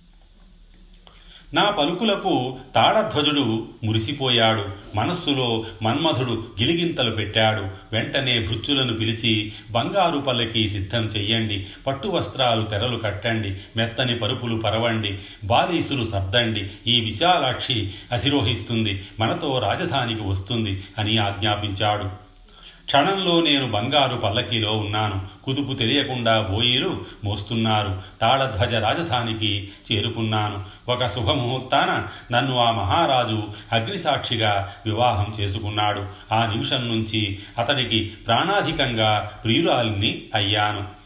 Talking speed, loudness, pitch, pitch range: 85 wpm, -22 LUFS, 110 Hz, 105-120 Hz